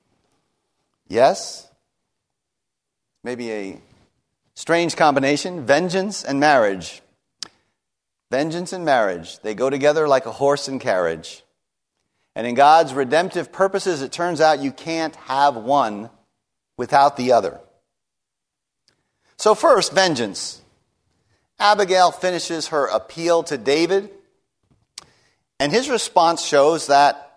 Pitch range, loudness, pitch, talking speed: 135-175 Hz, -19 LUFS, 150 Hz, 105 wpm